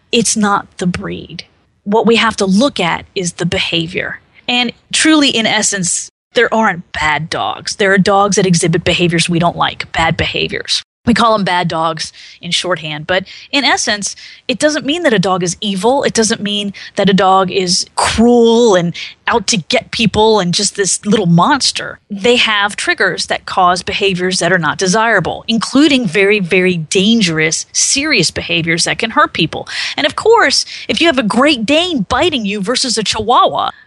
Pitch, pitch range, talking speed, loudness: 205 Hz, 180-235 Hz, 180 wpm, -12 LUFS